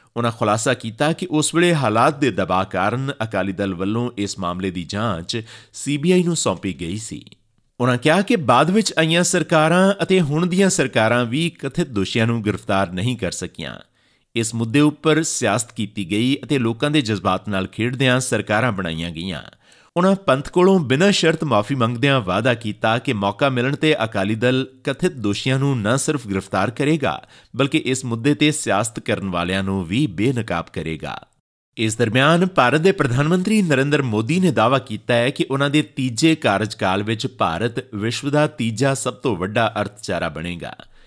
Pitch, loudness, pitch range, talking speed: 125 Hz, -19 LUFS, 105-150 Hz, 170 wpm